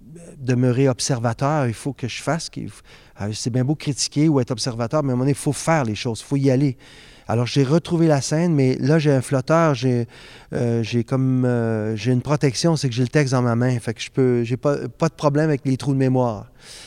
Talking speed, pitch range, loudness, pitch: 240 wpm, 125-145 Hz, -20 LUFS, 130 Hz